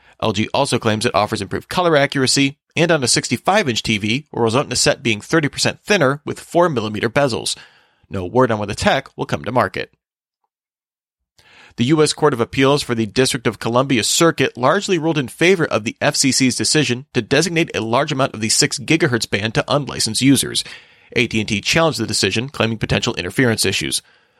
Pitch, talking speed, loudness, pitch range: 130 Hz, 180 wpm, -17 LUFS, 115-145 Hz